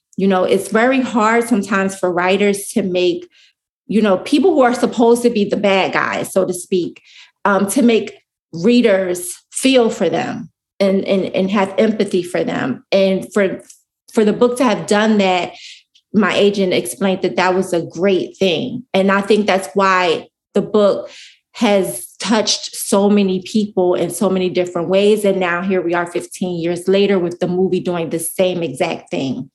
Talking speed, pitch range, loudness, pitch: 180 wpm, 185-220 Hz, -16 LUFS, 195 Hz